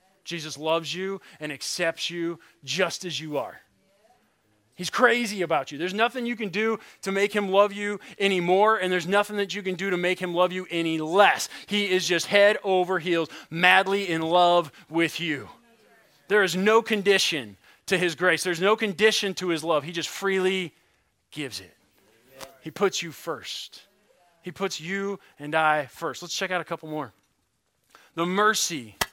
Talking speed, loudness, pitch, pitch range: 175 wpm, -24 LUFS, 180 Hz, 165-200 Hz